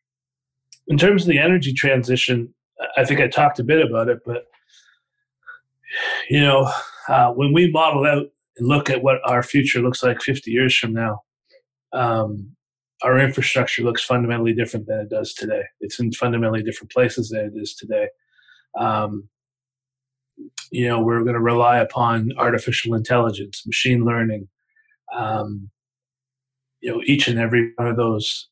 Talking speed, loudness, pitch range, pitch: 155 wpm, -19 LUFS, 115-135 Hz, 125 Hz